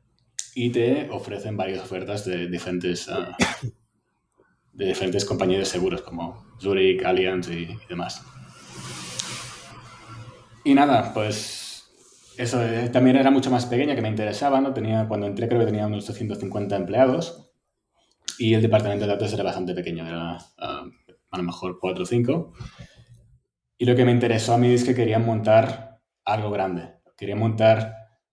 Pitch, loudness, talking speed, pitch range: 110 Hz, -23 LUFS, 155 wpm, 100-120 Hz